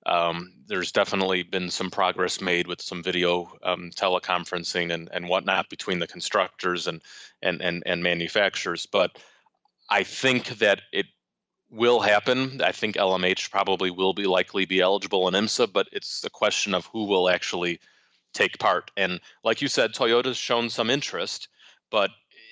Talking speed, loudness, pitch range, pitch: 160 wpm, -25 LUFS, 90-120 Hz, 95 Hz